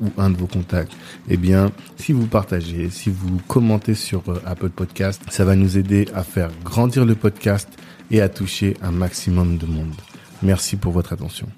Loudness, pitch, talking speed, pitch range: -20 LUFS, 95 Hz, 185 wpm, 90-100 Hz